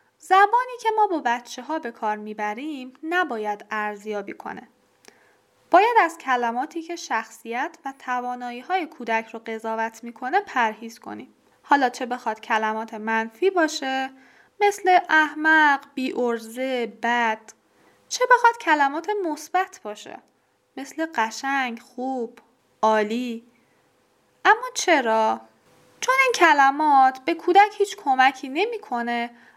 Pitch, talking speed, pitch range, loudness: 260 Hz, 115 wpm, 230-335 Hz, -22 LUFS